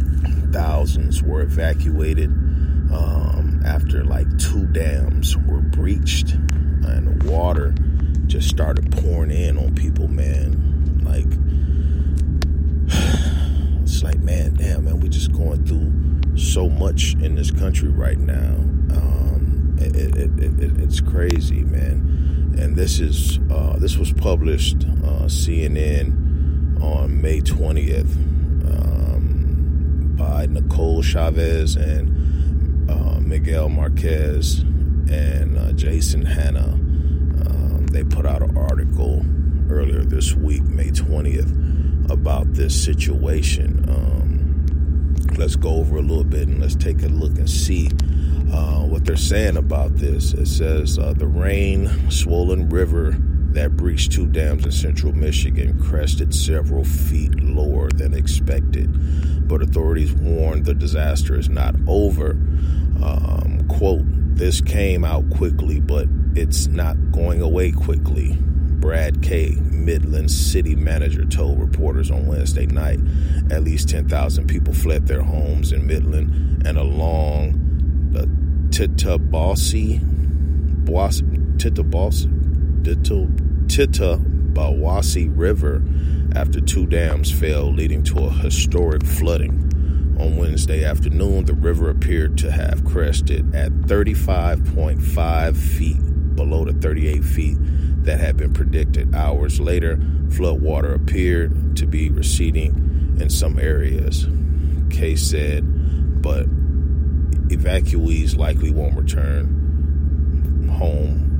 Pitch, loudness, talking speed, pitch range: 75 Hz, -19 LUFS, 115 wpm, 70-75 Hz